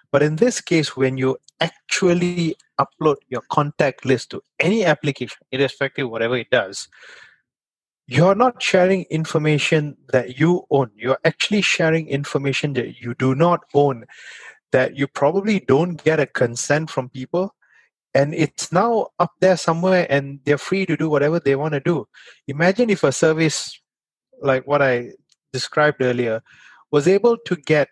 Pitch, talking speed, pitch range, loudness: 150 Hz, 160 wpm, 135-175 Hz, -19 LUFS